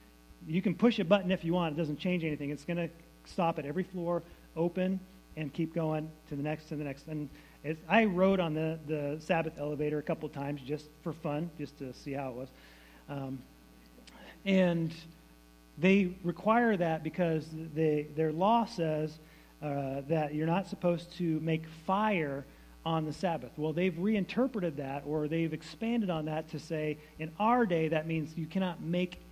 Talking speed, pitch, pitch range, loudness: 185 wpm, 160 Hz, 150-175 Hz, -33 LUFS